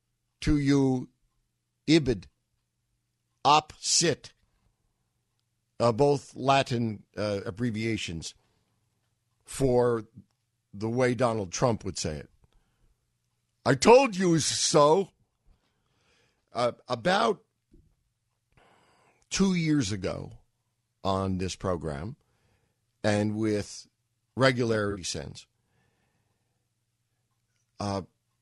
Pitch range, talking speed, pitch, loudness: 105-125 Hz, 75 wpm, 115 Hz, -27 LUFS